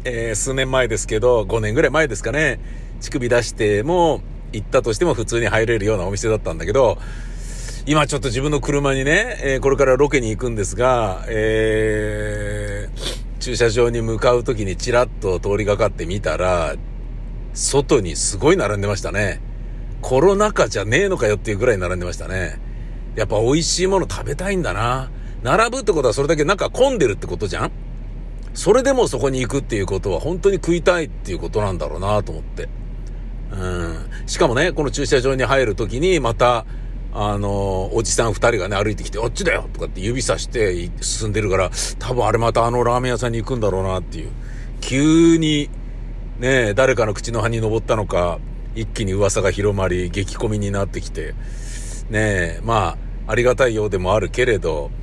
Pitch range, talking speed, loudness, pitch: 105-130 Hz, 370 characters per minute, -19 LUFS, 115 Hz